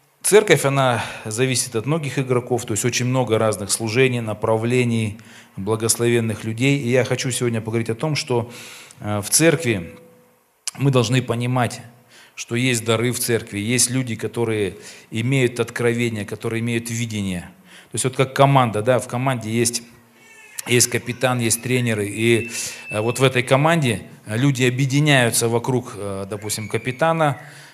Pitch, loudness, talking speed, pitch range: 120 Hz, -20 LUFS, 140 wpm, 115-130 Hz